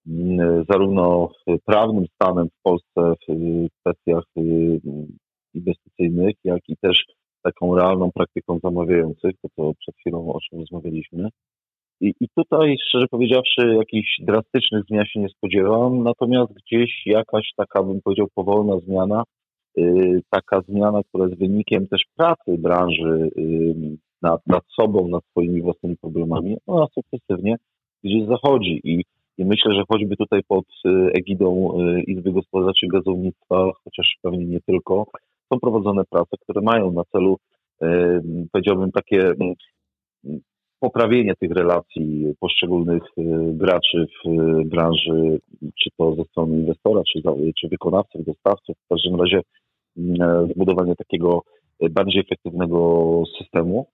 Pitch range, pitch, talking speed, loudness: 85-105 Hz, 90 Hz, 120 wpm, -20 LUFS